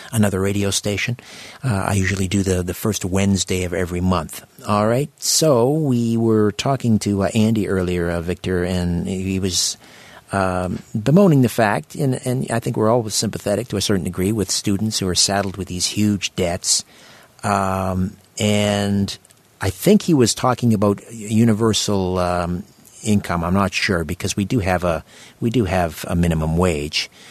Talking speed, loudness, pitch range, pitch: 170 wpm, -19 LUFS, 90-110 Hz, 100 Hz